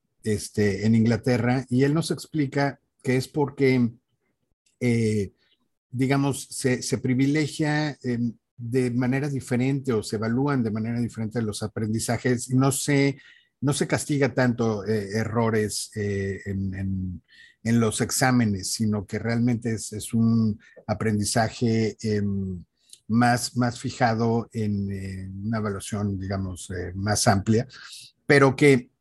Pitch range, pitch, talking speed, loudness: 105-130 Hz, 115 Hz, 130 wpm, -25 LUFS